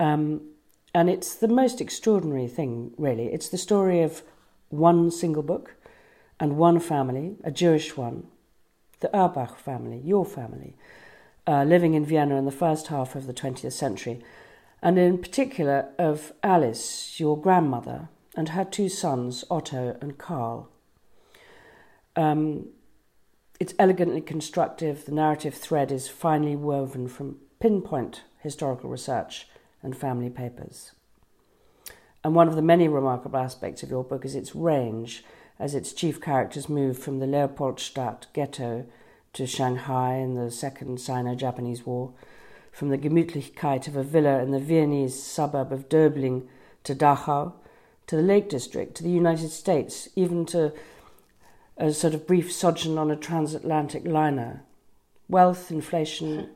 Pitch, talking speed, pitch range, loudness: 150 Hz, 140 wpm, 135-165 Hz, -25 LUFS